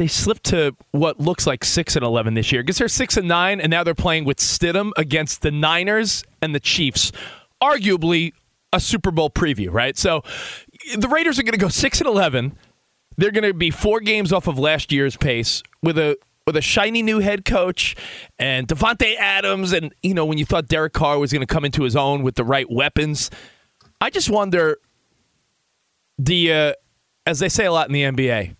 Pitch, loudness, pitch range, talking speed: 160 Hz, -19 LUFS, 140-200 Hz, 205 wpm